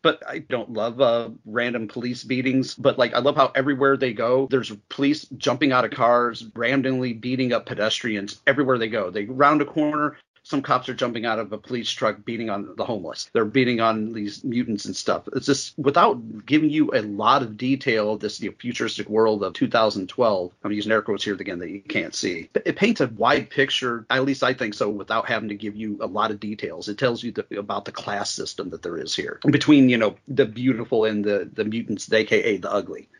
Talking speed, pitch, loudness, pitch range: 220 wpm, 120 Hz, -23 LUFS, 110-135 Hz